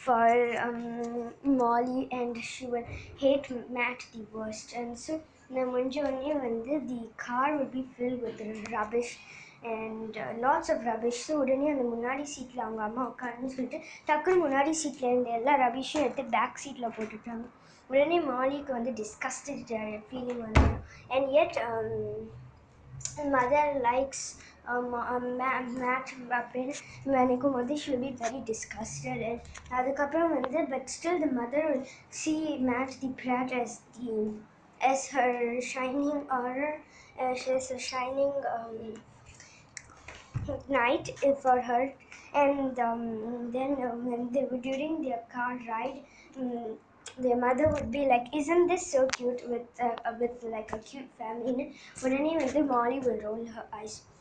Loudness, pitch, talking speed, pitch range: -31 LUFS, 250 Hz, 150 wpm, 235-275 Hz